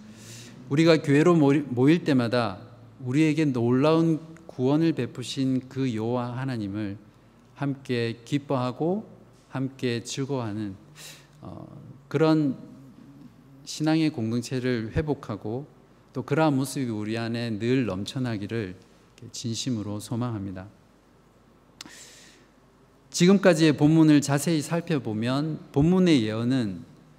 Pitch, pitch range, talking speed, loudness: 130 Hz, 115-150 Hz, 230 characters per minute, -25 LUFS